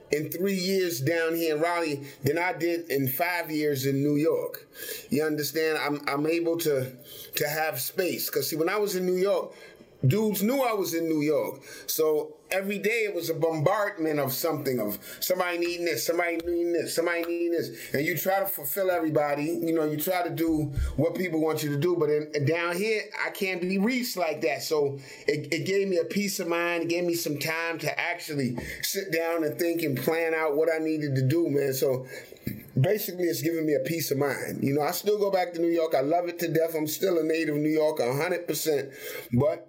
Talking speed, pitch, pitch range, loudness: 220 wpm, 165 Hz, 150-185 Hz, -27 LUFS